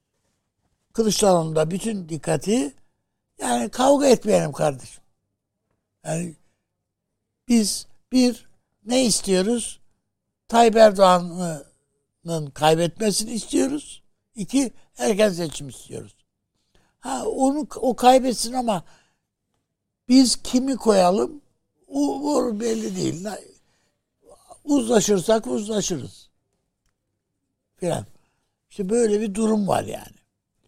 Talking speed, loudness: 80 wpm, -21 LUFS